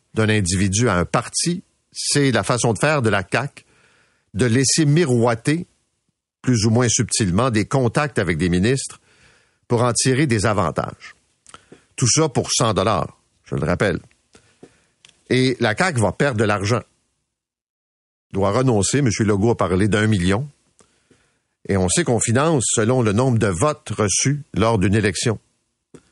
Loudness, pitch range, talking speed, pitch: -19 LUFS, 105-130 Hz, 155 wpm, 115 Hz